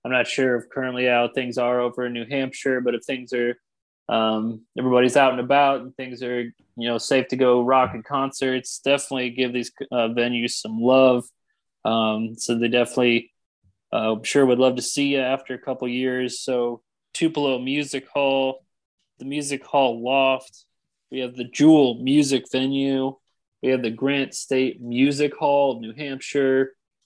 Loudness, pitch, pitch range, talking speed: -22 LUFS, 130 Hz, 120-135 Hz, 175 wpm